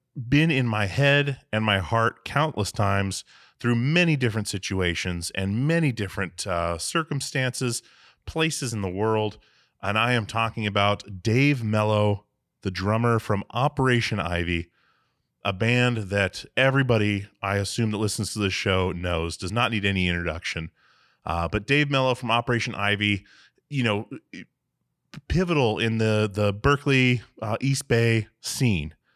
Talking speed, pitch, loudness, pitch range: 140 wpm, 110 Hz, -24 LUFS, 100-125 Hz